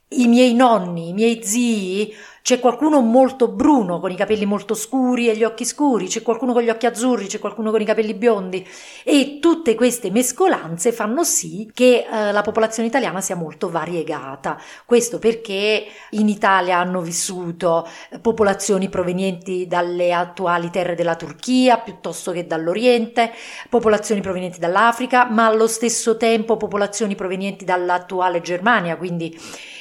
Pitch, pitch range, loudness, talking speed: 215 Hz, 185-235 Hz, -18 LUFS, 145 wpm